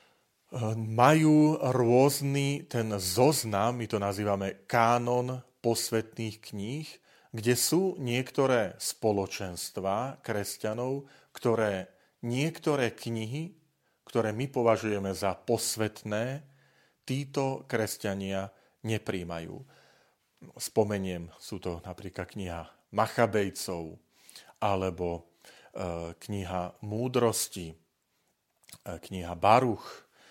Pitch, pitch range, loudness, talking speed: 110 Hz, 95-125 Hz, -30 LUFS, 75 wpm